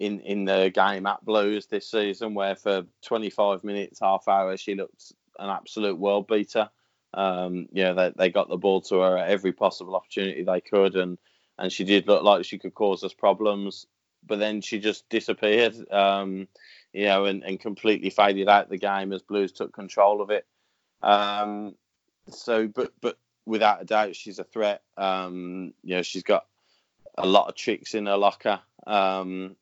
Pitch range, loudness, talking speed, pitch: 95-105 Hz, -25 LUFS, 185 wpm, 100 Hz